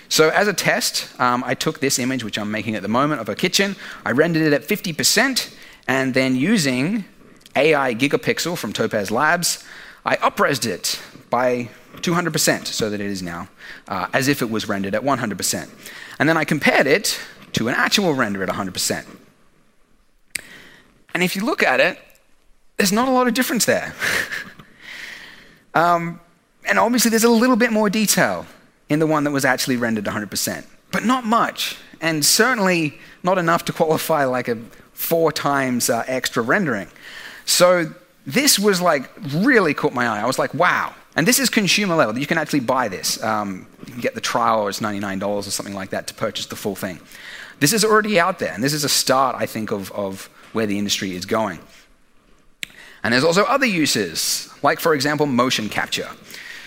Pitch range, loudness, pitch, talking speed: 125-200 Hz, -19 LUFS, 155 Hz, 185 wpm